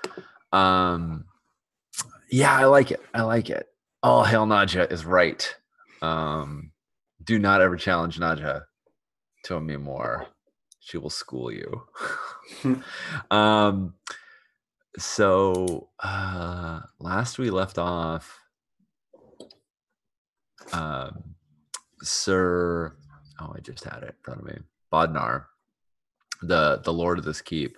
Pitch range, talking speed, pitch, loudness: 80-100 Hz, 110 wpm, 90 Hz, -24 LUFS